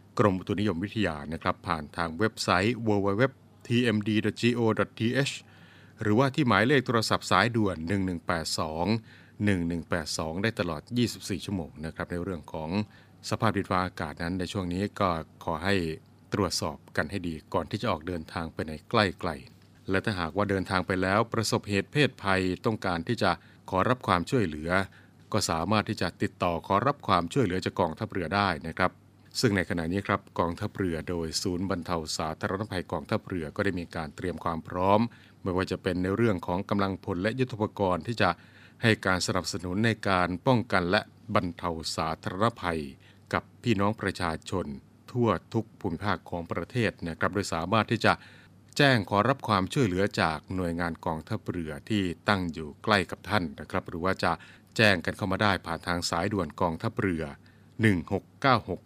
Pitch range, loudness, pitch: 85-110 Hz, -29 LUFS, 95 Hz